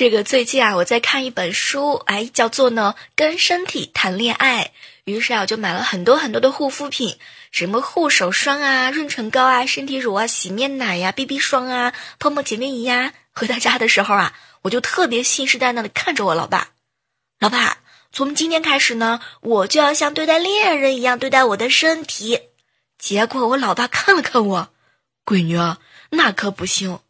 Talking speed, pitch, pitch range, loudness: 280 characters per minute, 255 Hz, 225-280 Hz, -17 LUFS